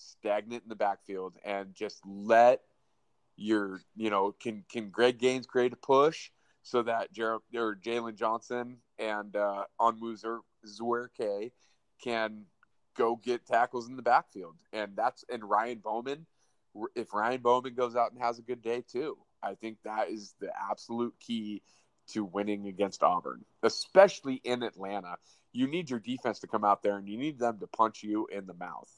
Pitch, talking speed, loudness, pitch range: 115 Hz, 170 wpm, -32 LUFS, 105-120 Hz